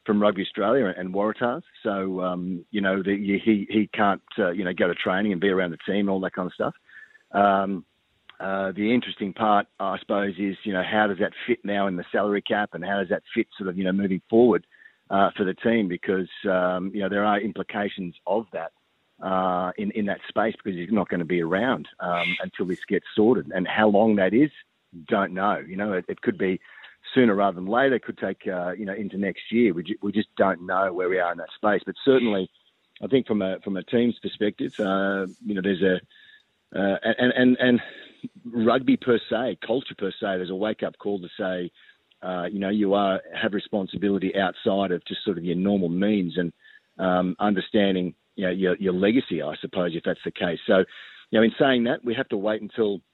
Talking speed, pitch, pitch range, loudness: 225 wpm, 100 Hz, 95-105 Hz, -25 LUFS